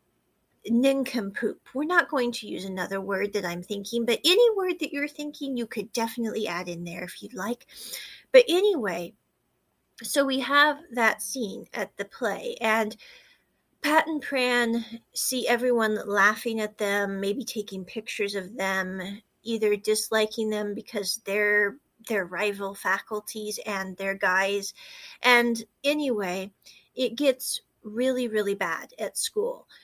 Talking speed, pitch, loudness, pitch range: 140 wpm, 225 Hz, -26 LUFS, 205-265 Hz